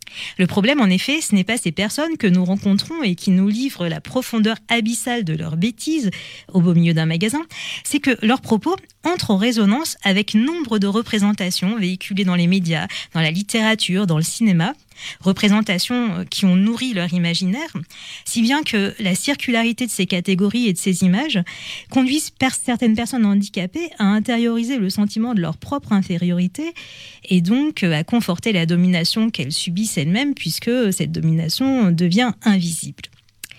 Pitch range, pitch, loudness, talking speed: 180-235 Hz, 205 Hz, -19 LUFS, 165 wpm